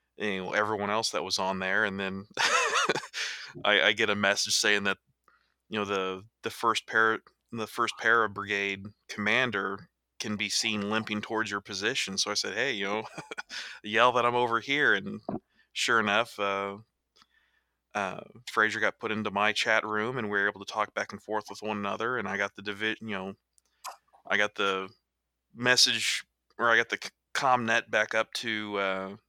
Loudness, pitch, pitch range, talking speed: -28 LUFS, 105 Hz, 100-110 Hz, 190 wpm